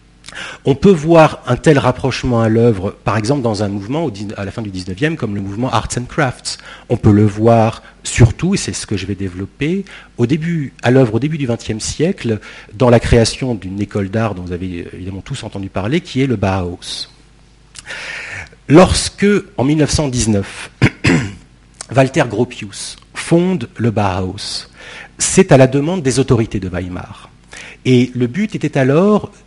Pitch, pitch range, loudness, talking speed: 120 Hz, 100-140 Hz, -15 LUFS, 170 wpm